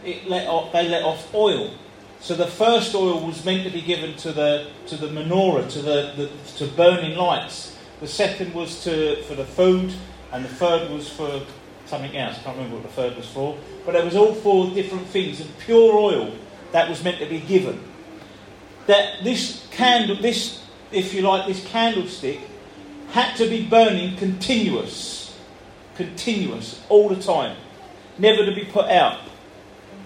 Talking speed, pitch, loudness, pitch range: 175 wpm, 180 Hz, -21 LUFS, 155-200 Hz